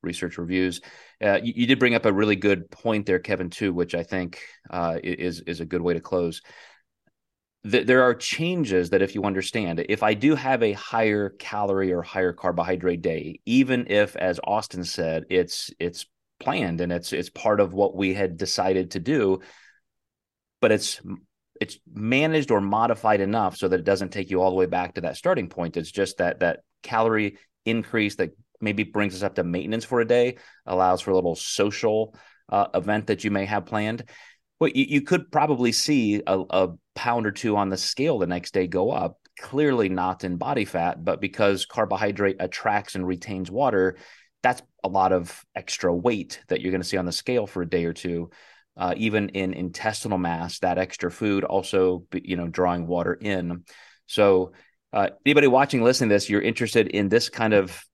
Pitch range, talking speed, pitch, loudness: 90-110 Hz, 195 wpm, 95 Hz, -24 LUFS